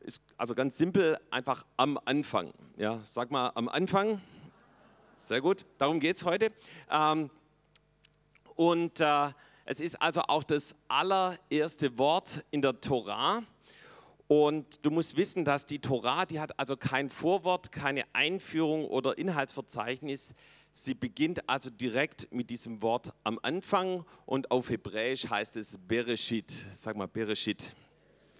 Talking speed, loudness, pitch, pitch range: 135 wpm, -31 LUFS, 145 Hz, 125-160 Hz